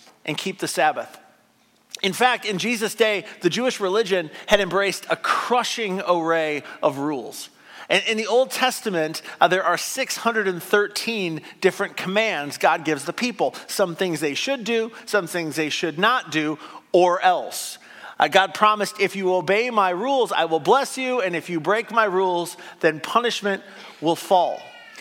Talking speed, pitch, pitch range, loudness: 165 wpm, 195 Hz, 170-220 Hz, -22 LUFS